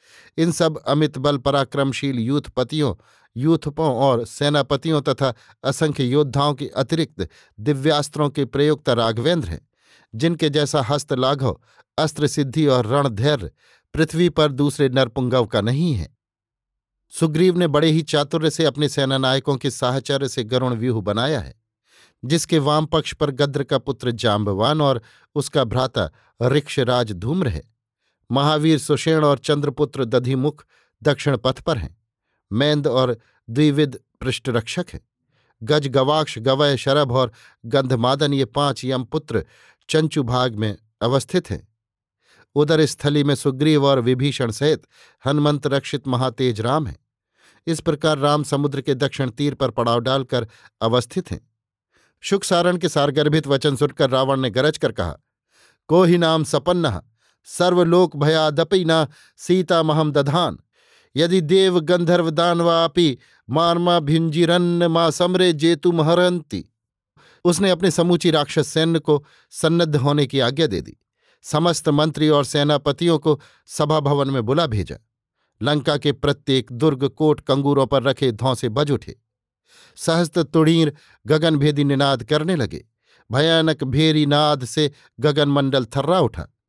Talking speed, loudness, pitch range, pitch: 130 wpm, -19 LUFS, 130-155 Hz, 145 Hz